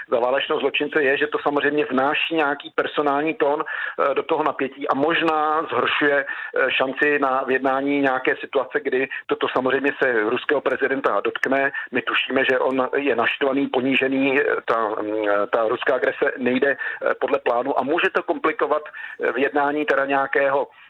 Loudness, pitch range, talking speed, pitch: -21 LUFS, 135-155 Hz, 140 wpm, 140 Hz